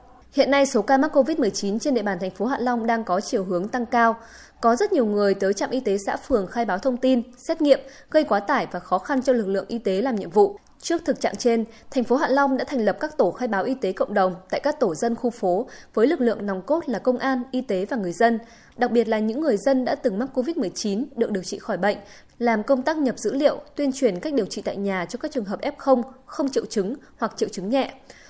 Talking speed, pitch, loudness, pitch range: 270 wpm, 245 Hz, -23 LUFS, 205-270 Hz